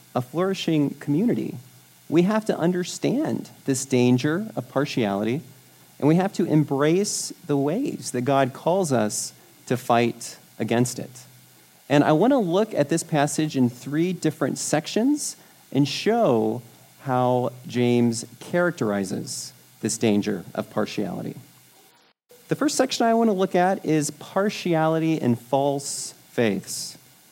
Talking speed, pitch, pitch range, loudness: 130 wpm, 145 Hz, 125-175 Hz, -23 LUFS